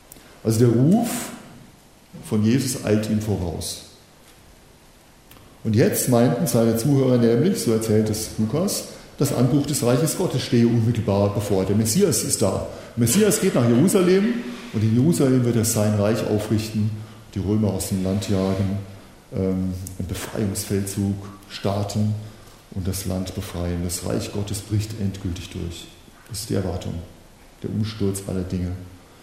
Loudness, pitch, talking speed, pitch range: -22 LUFS, 105 Hz, 145 wpm, 95-120 Hz